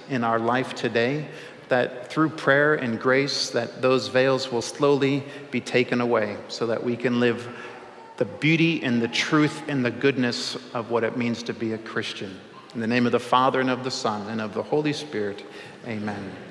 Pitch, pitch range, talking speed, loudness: 125 Hz, 115-140 Hz, 195 wpm, -24 LUFS